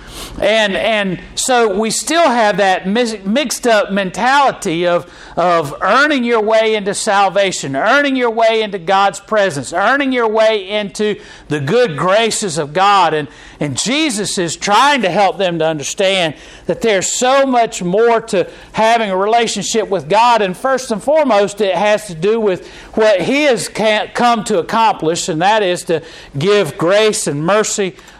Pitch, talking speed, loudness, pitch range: 210 Hz, 160 wpm, -14 LUFS, 180-230 Hz